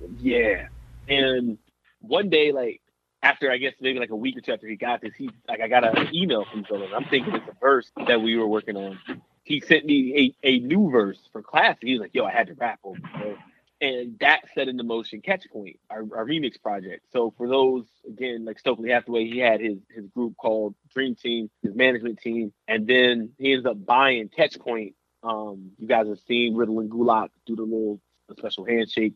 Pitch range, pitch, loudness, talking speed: 110-130 Hz, 120 Hz, -23 LUFS, 220 wpm